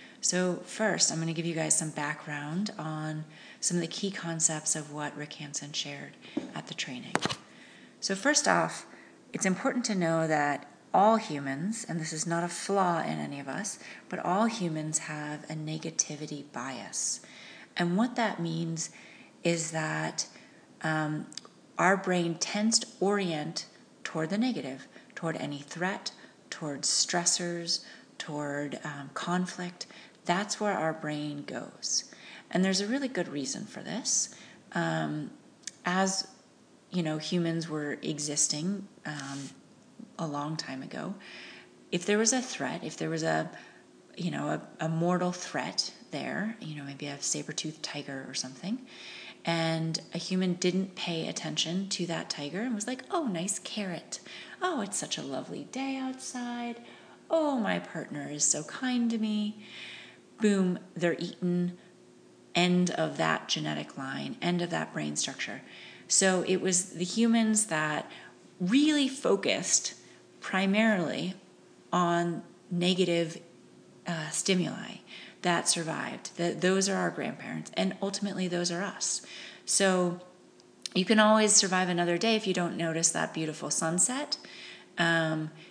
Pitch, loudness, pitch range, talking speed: 175 Hz, -30 LUFS, 155-200 Hz, 145 wpm